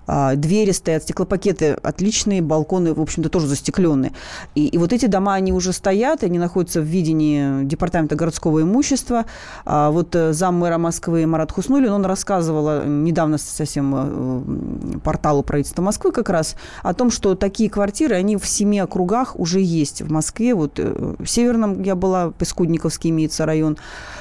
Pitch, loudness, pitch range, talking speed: 170 Hz, -19 LUFS, 155-195 Hz, 150 wpm